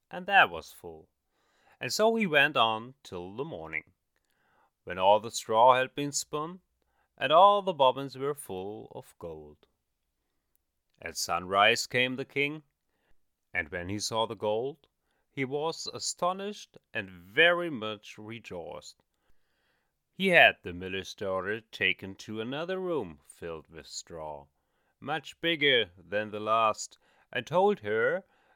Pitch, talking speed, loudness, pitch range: 115 Hz, 135 wpm, -28 LUFS, 95-150 Hz